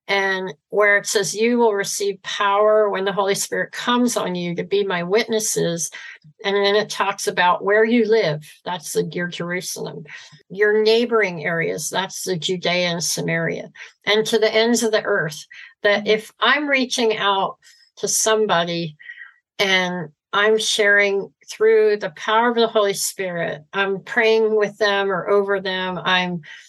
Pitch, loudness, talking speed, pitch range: 200 Hz, -19 LUFS, 160 wpm, 180-220 Hz